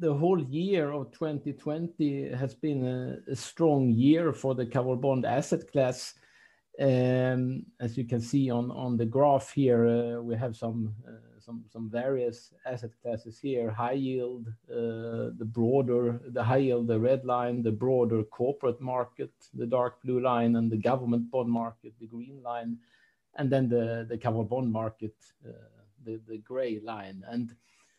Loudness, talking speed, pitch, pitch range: -29 LUFS, 160 wpm, 120 Hz, 115-135 Hz